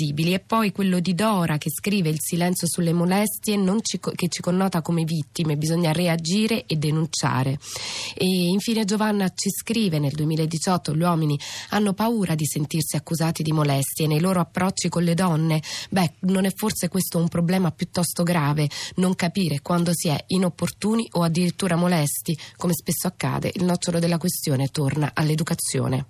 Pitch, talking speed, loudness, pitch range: 170 Hz, 165 wpm, -23 LUFS, 155-185 Hz